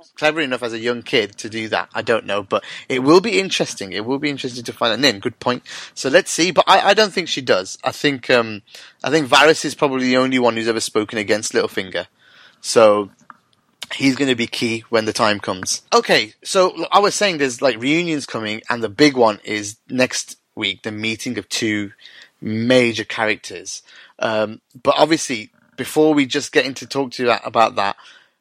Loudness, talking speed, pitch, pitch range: -18 LUFS, 205 wpm, 130 Hz, 110-150 Hz